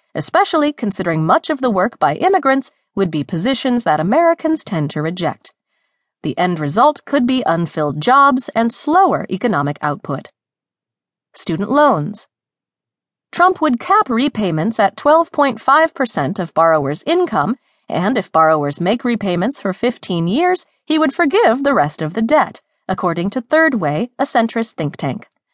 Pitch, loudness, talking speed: 235 Hz, -16 LUFS, 145 wpm